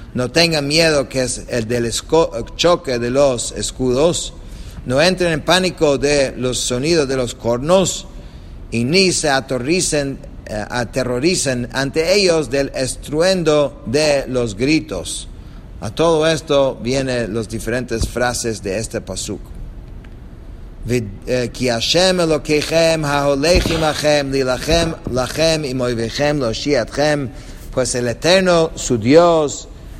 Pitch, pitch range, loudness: 135 Hz, 120-155 Hz, -17 LUFS